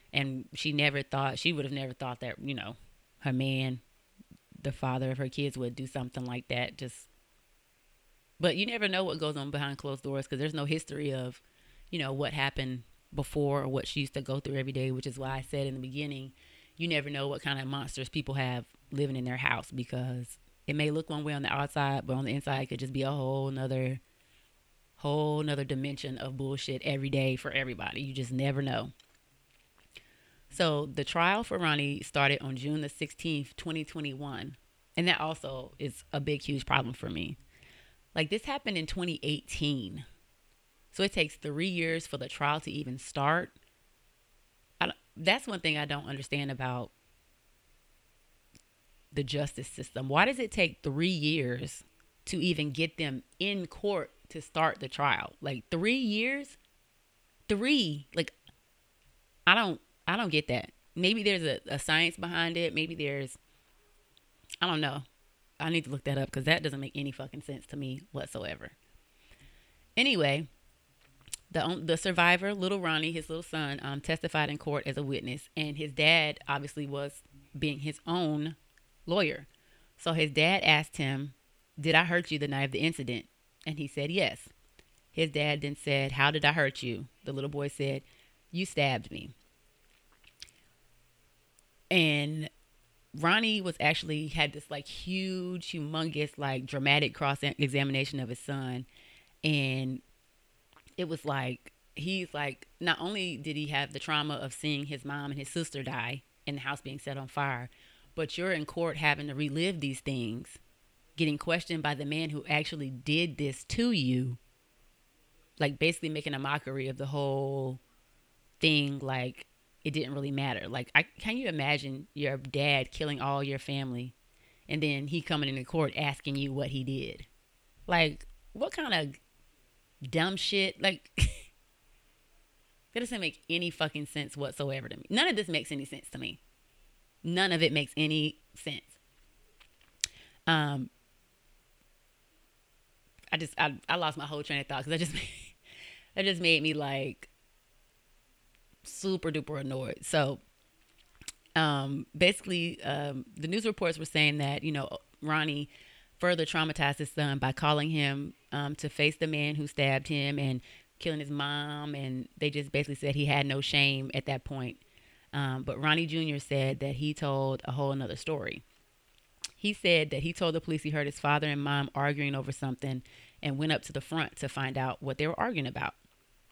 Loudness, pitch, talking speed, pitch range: -32 LUFS, 145 Hz, 175 wpm, 135-155 Hz